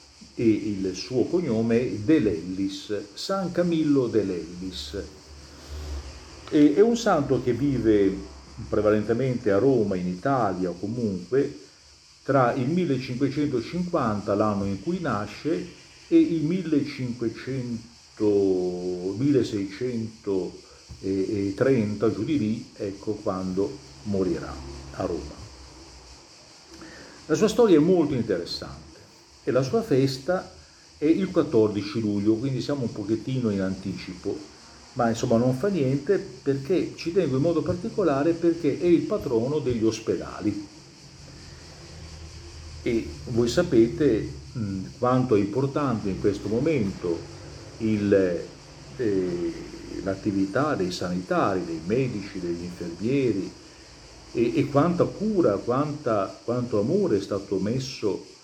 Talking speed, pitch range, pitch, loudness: 110 wpm, 95-140 Hz, 115 Hz, -25 LUFS